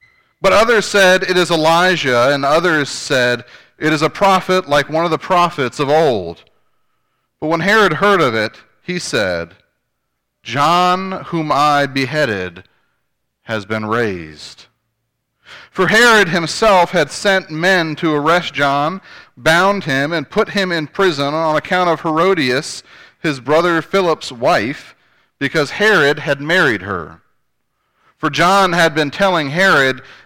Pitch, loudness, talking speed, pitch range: 160 Hz, -14 LUFS, 140 wpm, 140-185 Hz